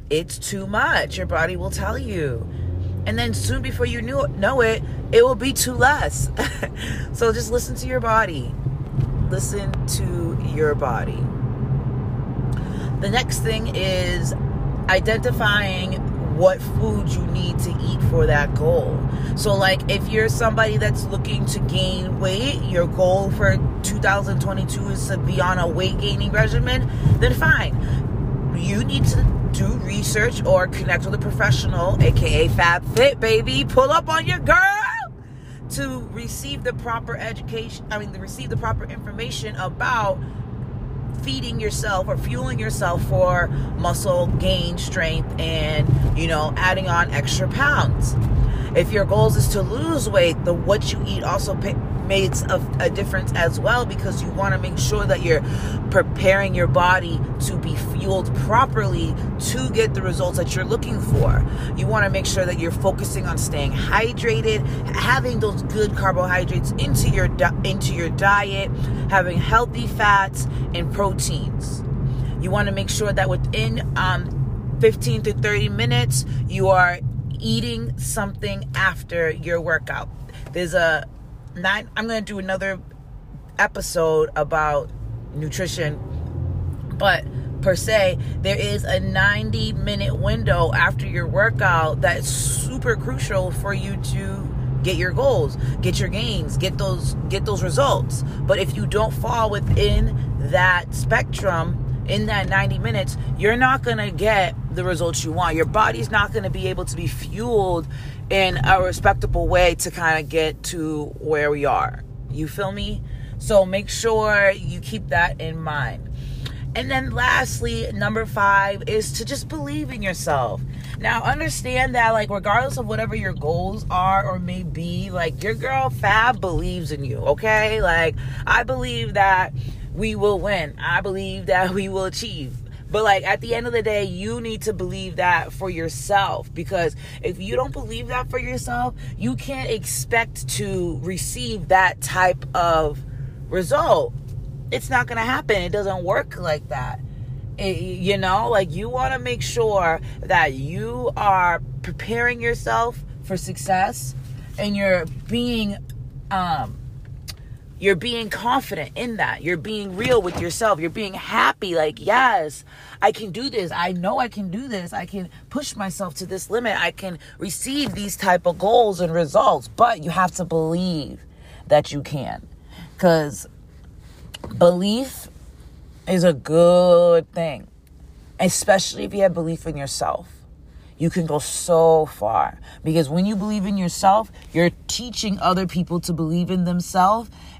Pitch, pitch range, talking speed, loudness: 135 Hz, 125-175 Hz, 155 wpm, -21 LUFS